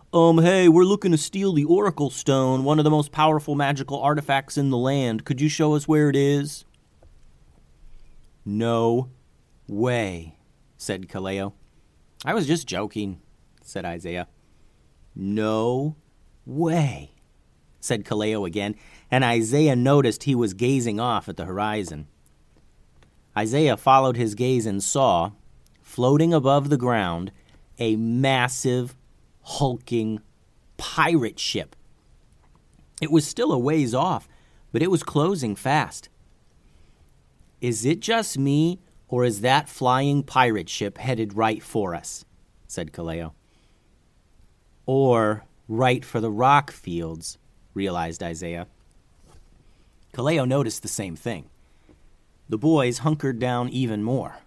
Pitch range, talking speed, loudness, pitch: 90-140 Hz, 125 wpm, -23 LUFS, 120 Hz